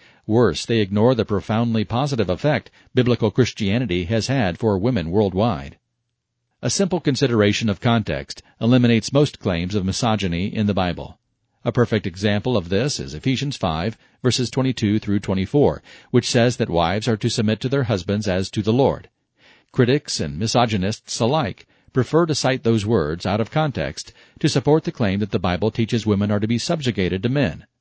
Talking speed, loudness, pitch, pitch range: 175 wpm, -21 LUFS, 115 Hz, 100-125 Hz